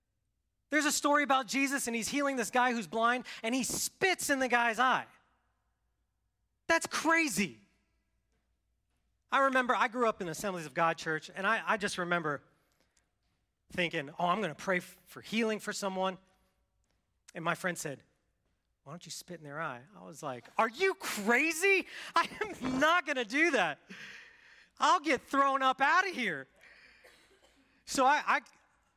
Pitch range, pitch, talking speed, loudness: 170-275 Hz, 225 Hz, 170 wpm, -31 LUFS